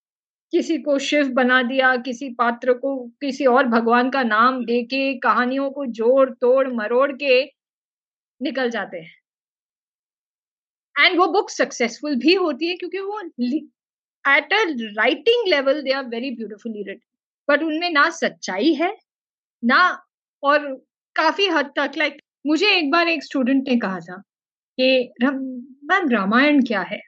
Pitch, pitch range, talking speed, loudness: 270 Hz, 250-305 Hz, 145 wpm, -19 LUFS